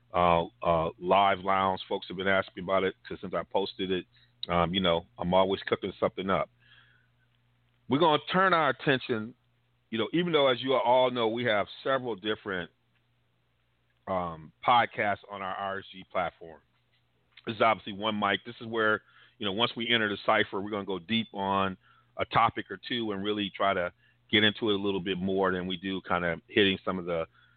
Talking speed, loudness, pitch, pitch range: 200 wpm, -29 LUFS, 100 Hz, 95-120 Hz